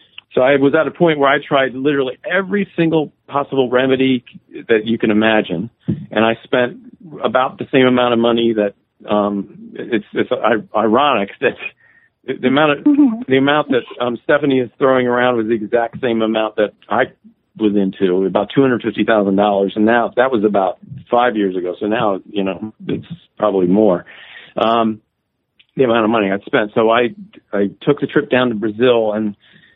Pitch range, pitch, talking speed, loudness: 110-140 Hz, 120 Hz, 185 wpm, -16 LUFS